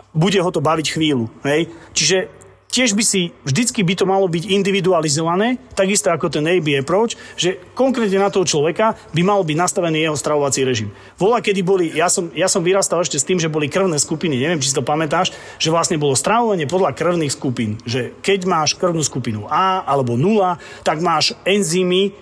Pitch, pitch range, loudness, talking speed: 175 Hz, 150-195 Hz, -17 LUFS, 190 wpm